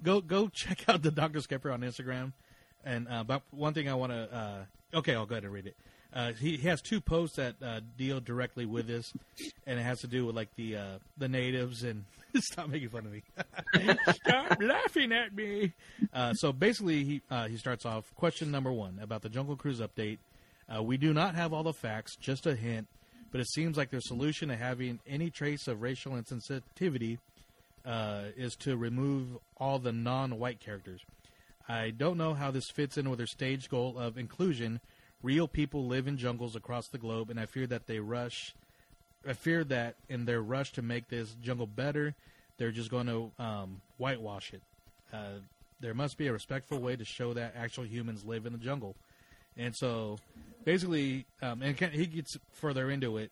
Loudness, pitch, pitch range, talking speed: -35 LUFS, 125 Hz, 115-145 Hz, 200 wpm